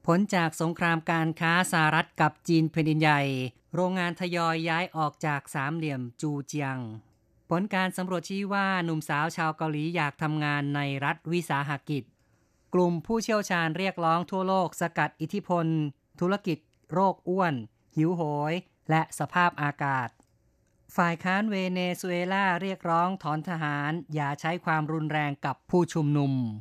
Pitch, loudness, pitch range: 160 Hz, -28 LUFS, 145-175 Hz